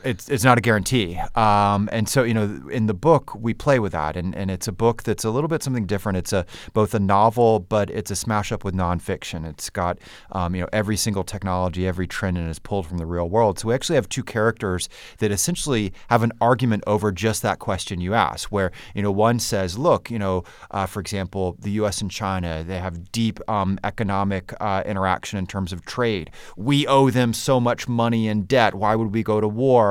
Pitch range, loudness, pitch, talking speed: 95-115 Hz, -22 LUFS, 105 Hz, 230 wpm